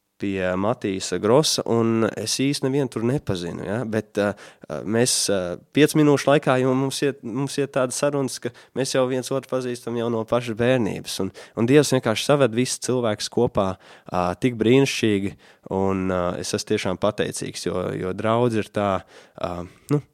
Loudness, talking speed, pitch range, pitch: -22 LUFS, 155 wpm, 100-130 Hz, 115 Hz